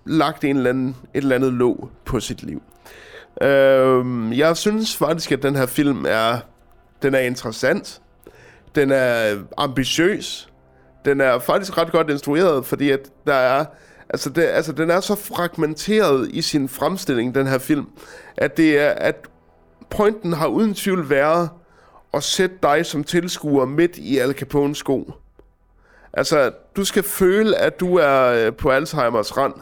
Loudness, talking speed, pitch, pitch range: -19 LUFS, 160 wpm, 145 Hz, 130-170 Hz